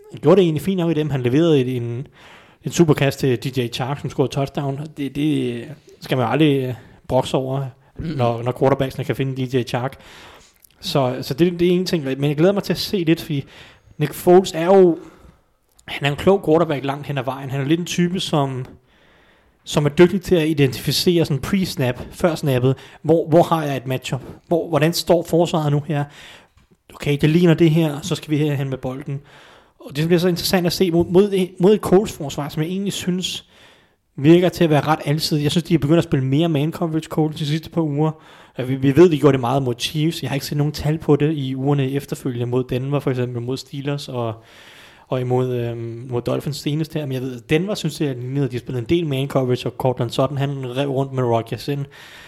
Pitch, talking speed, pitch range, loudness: 145 Hz, 225 wpm, 130-165 Hz, -19 LUFS